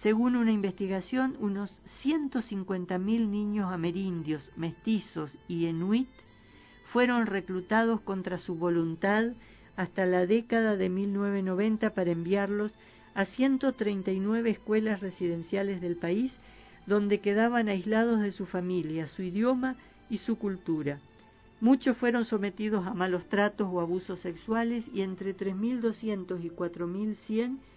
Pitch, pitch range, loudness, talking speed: 200 Hz, 185-225 Hz, -30 LUFS, 130 wpm